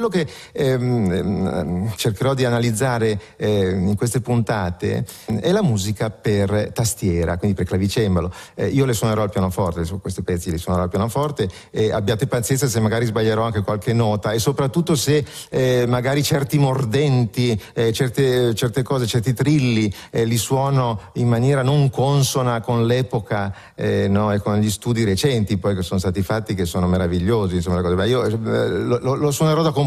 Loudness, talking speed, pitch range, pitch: -20 LUFS, 175 wpm, 100-130 Hz, 115 Hz